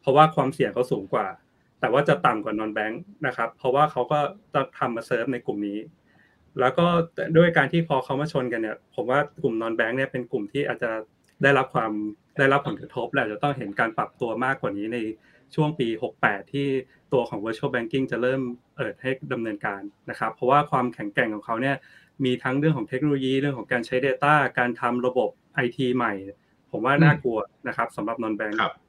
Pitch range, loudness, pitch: 115-145 Hz, -25 LUFS, 130 Hz